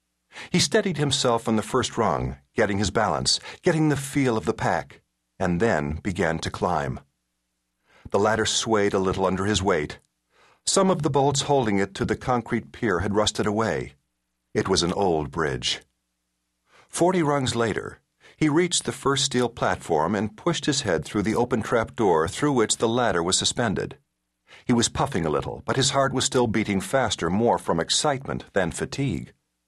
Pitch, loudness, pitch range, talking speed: 115 Hz, -24 LUFS, 85-140 Hz, 180 wpm